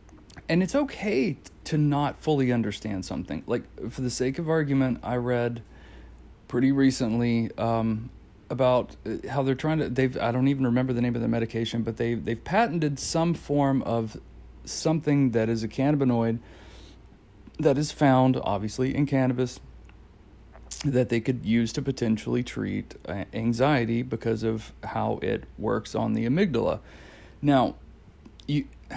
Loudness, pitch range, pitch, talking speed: -26 LUFS, 115-140 Hz, 125 Hz, 145 wpm